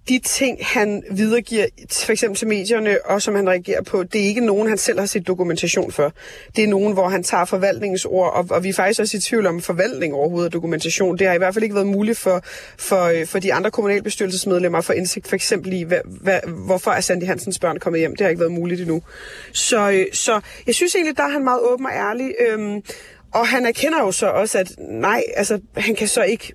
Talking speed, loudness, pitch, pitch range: 230 wpm, -19 LUFS, 200 Hz, 185-225 Hz